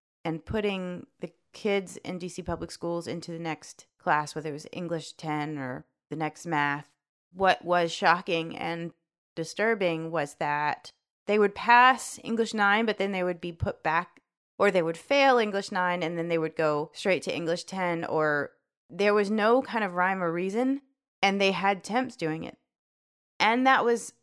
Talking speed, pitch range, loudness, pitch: 180 wpm, 160-205 Hz, -27 LUFS, 175 Hz